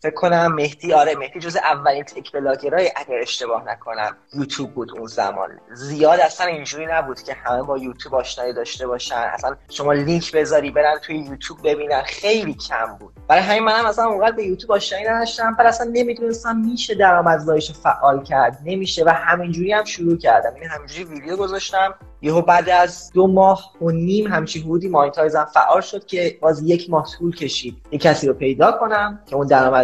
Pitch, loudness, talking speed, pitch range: 165 Hz, -18 LUFS, 180 wpm, 145-195 Hz